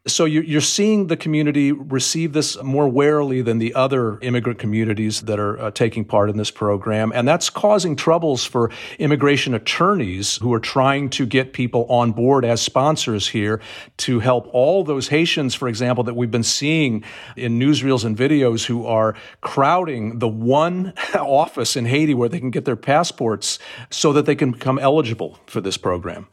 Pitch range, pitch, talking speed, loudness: 115-150 Hz, 130 Hz, 175 wpm, -19 LUFS